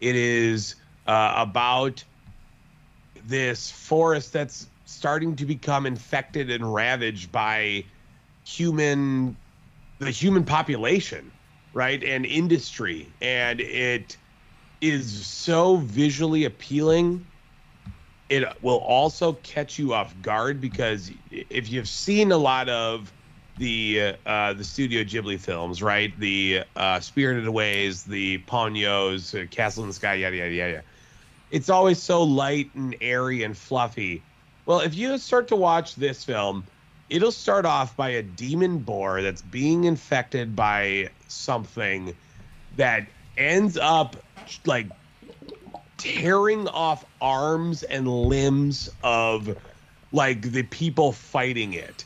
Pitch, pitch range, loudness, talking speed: 130 Hz, 105-150 Hz, -24 LUFS, 120 wpm